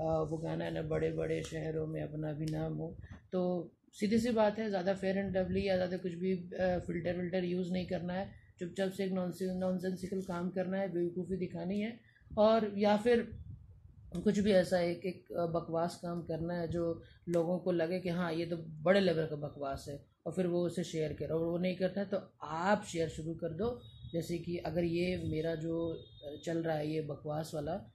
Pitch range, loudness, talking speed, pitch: 160-185 Hz, -35 LUFS, 210 wpm, 175 Hz